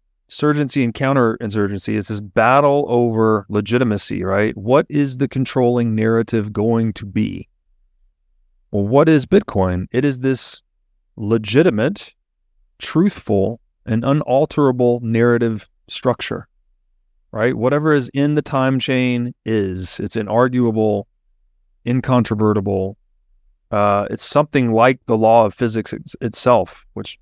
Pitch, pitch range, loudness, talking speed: 110 Hz, 100-130 Hz, -17 LUFS, 110 wpm